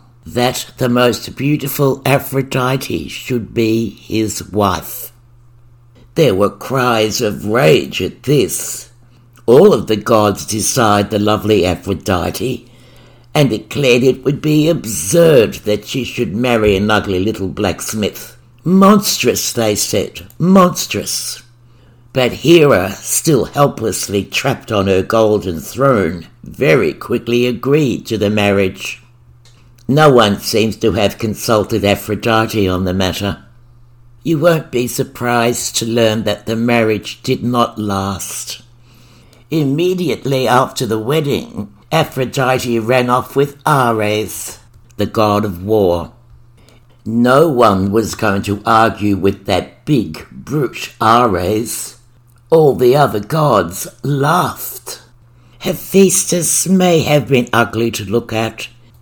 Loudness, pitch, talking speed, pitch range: -14 LUFS, 120 Hz, 120 wpm, 105-130 Hz